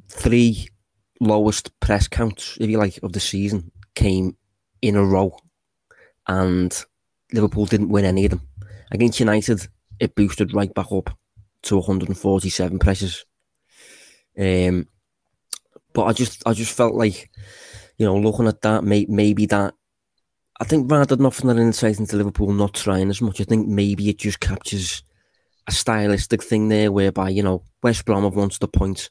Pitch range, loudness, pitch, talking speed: 95-110 Hz, -20 LUFS, 105 Hz, 165 wpm